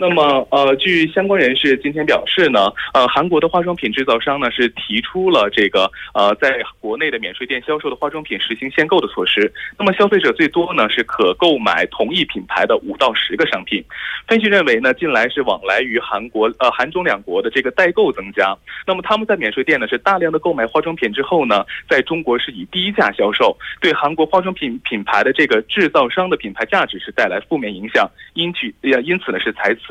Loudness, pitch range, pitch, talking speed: -16 LUFS, 135-190 Hz, 165 Hz, 330 characters per minute